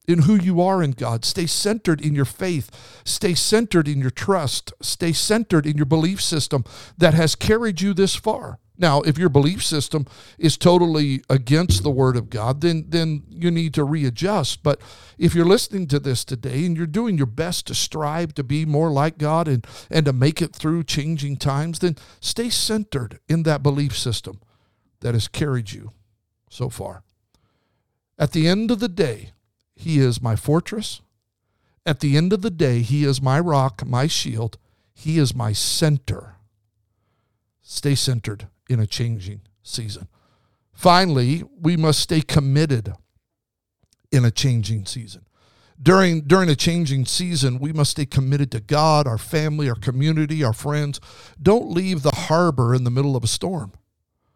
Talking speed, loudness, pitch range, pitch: 170 wpm, -20 LUFS, 115-165 Hz, 140 Hz